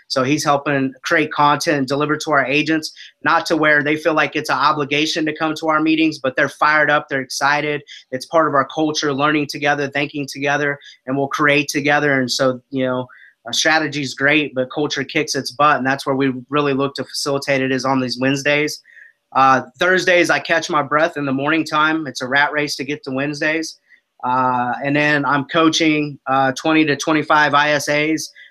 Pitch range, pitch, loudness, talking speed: 135-155 Hz, 145 Hz, -17 LUFS, 200 wpm